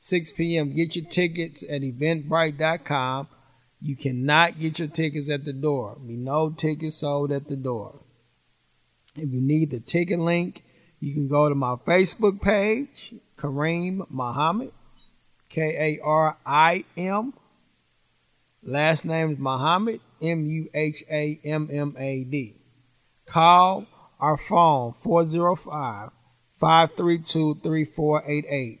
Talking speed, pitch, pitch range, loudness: 125 wpm, 155 Hz, 140-165 Hz, -24 LUFS